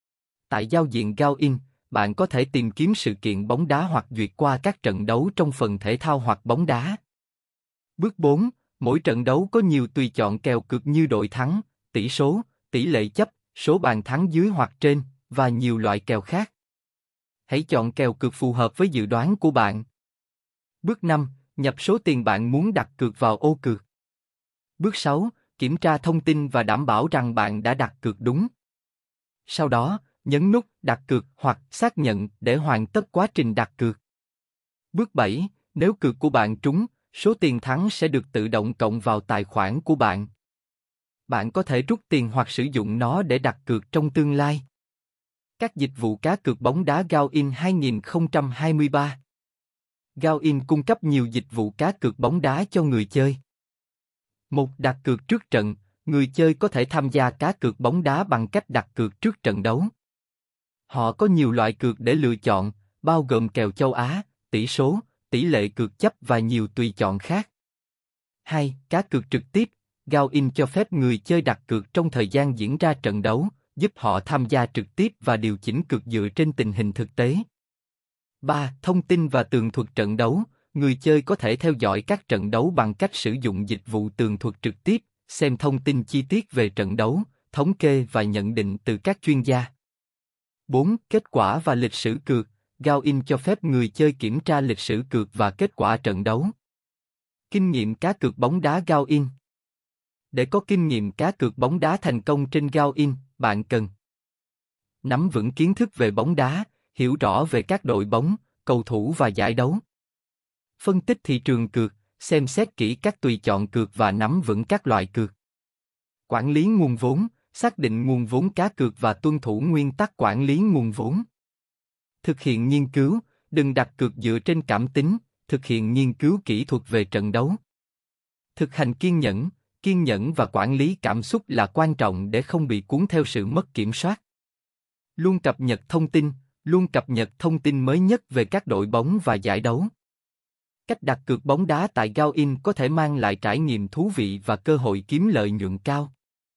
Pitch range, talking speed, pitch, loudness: 115-160 Hz, 195 wpm, 135 Hz, -23 LUFS